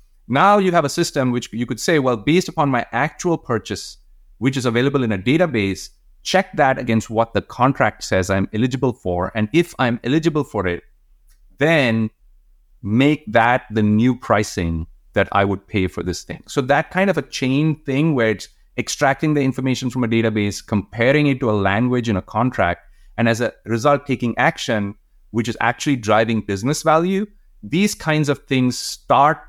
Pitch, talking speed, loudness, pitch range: 120 Hz, 185 wpm, -19 LUFS, 105-145 Hz